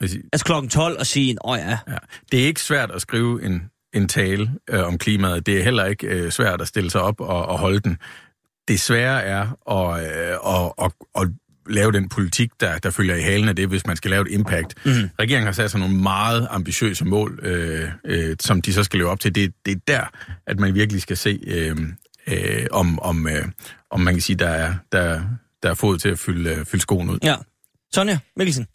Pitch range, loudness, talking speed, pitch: 90-115 Hz, -21 LUFS, 175 wpm, 100 Hz